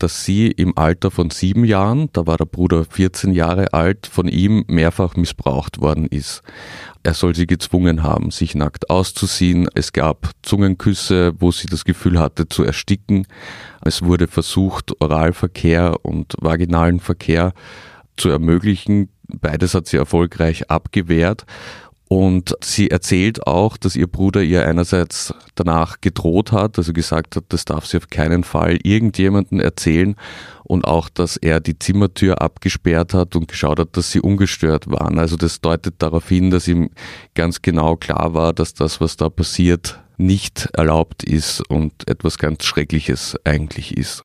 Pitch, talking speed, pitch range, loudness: 85 Hz, 155 wpm, 80-95 Hz, -17 LUFS